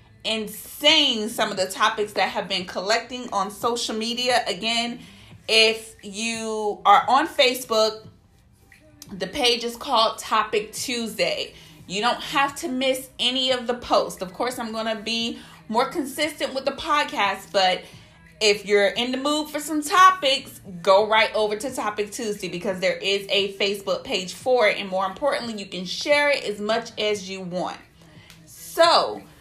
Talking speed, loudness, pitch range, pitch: 165 wpm, -22 LUFS, 200-260 Hz, 225 Hz